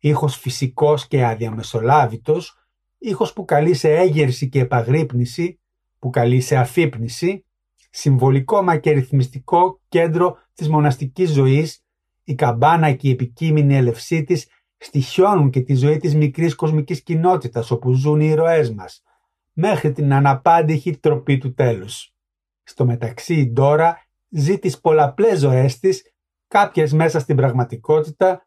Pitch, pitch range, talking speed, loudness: 150 Hz, 130-170 Hz, 130 wpm, -18 LUFS